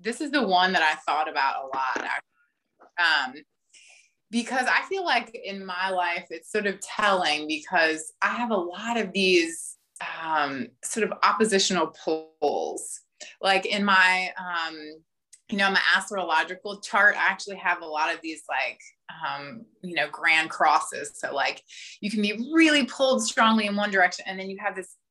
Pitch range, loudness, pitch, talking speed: 175-225 Hz, -24 LUFS, 195 Hz, 170 wpm